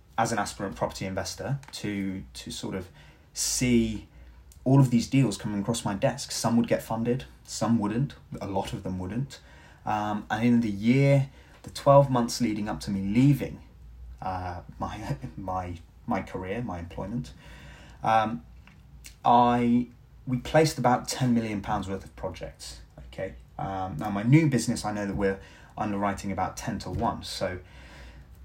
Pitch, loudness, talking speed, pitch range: 105 Hz, -27 LUFS, 160 wpm, 90-120 Hz